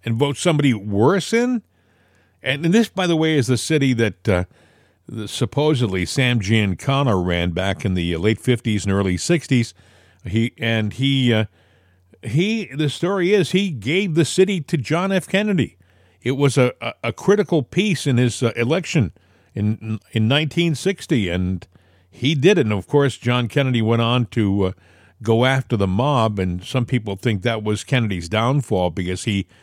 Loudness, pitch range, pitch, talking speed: -20 LUFS, 100-145 Hz, 115 Hz, 175 wpm